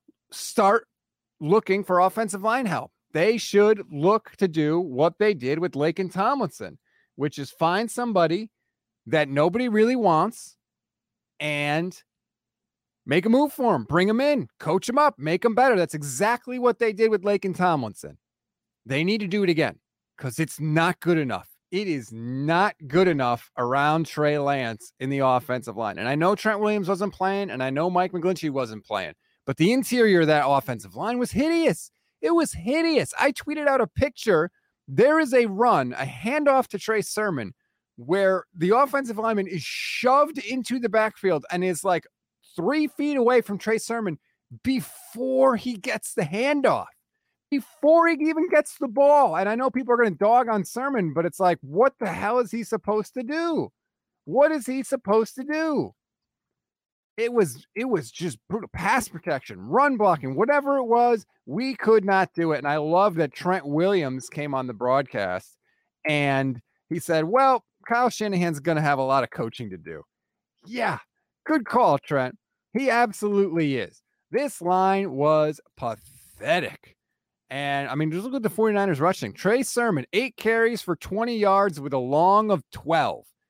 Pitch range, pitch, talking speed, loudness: 155-240 Hz, 195 Hz, 175 wpm, -23 LUFS